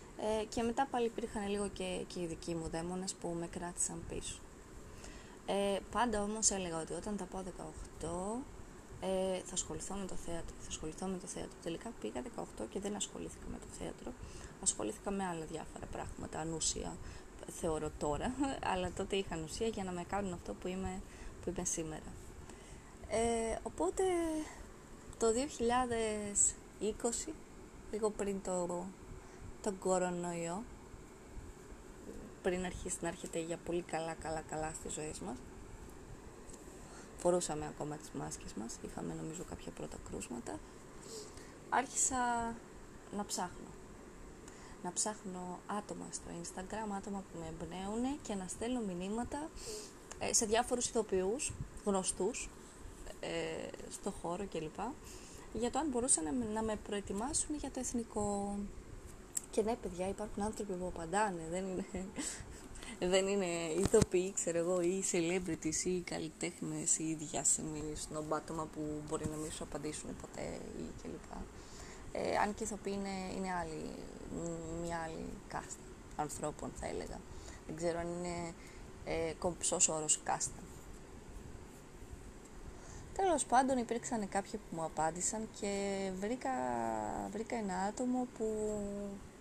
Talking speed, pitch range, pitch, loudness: 130 wpm, 170-220 Hz, 190 Hz, -38 LUFS